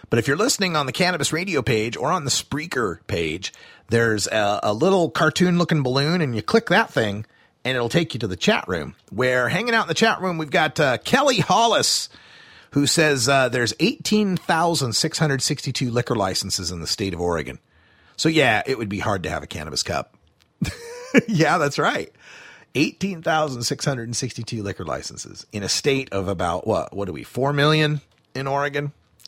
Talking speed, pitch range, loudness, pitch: 195 wpm, 115-165 Hz, -21 LUFS, 140 Hz